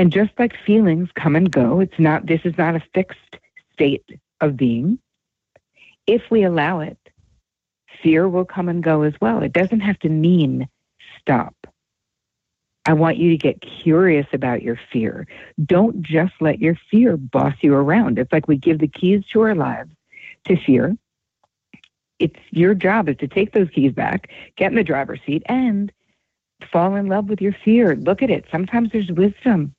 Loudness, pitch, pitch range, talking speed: -18 LUFS, 175 Hz, 155-205 Hz, 180 wpm